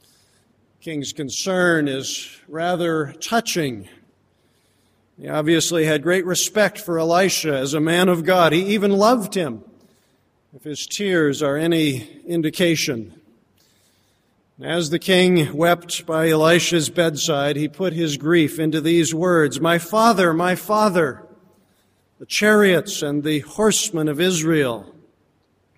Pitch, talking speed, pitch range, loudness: 165 Hz, 120 wpm, 150-180 Hz, -19 LUFS